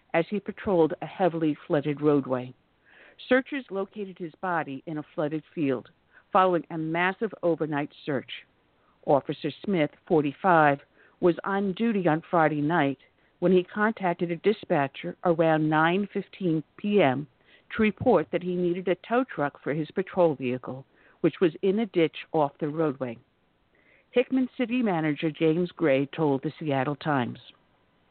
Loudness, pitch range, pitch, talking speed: -27 LUFS, 150-185 Hz, 165 Hz, 140 wpm